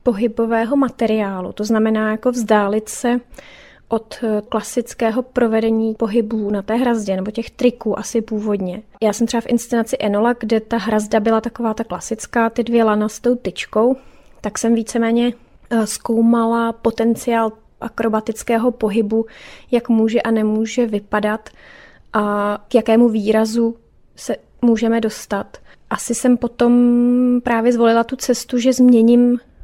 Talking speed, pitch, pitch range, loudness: 135 wpm, 230 Hz, 220-240 Hz, -18 LUFS